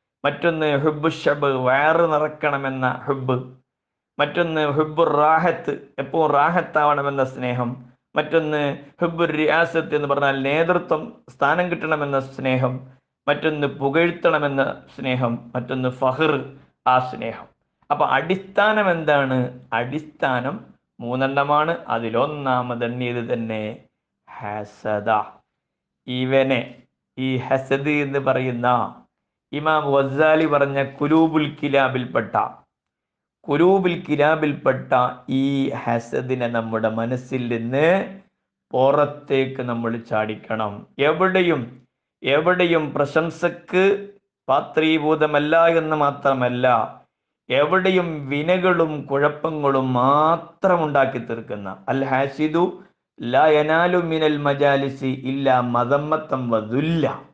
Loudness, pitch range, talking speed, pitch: -21 LUFS, 130-155 Hz, 70 wpm, 140 Hz